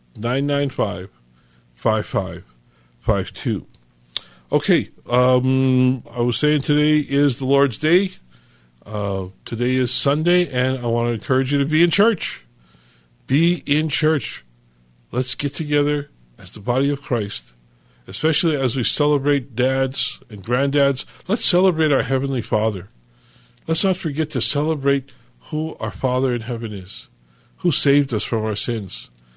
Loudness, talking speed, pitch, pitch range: -20 LUFS, 145 wpm, 125 Hz, 100-145 Hz